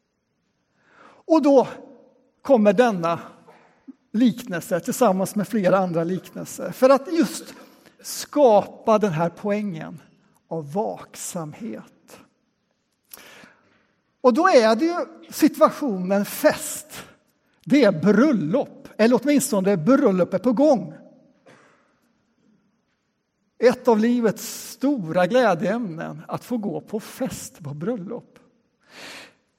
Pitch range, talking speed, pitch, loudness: 200-260 Hz, 95 wpm, 235 Hz, -21 LUFS